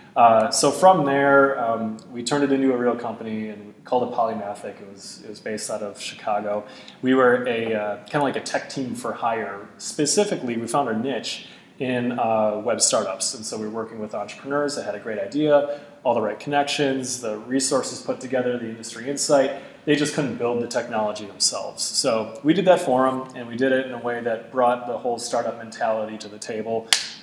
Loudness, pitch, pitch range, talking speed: -23 LUFS, 125 Hz, 110-140 Hz, 215 wpm